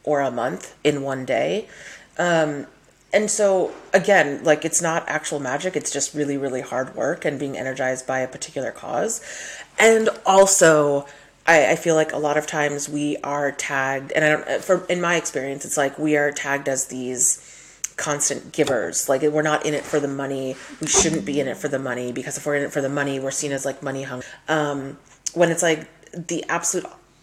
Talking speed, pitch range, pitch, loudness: 205 wpm, 135-160 Hz, 145 Hz, -21 LUFS